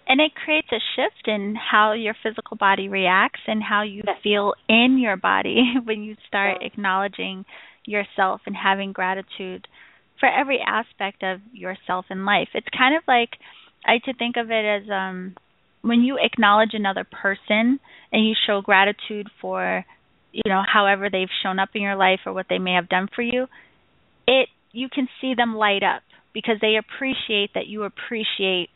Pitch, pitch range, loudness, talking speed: 210 Hz, 195-235 Hz, -21 LUFS, 175 wpm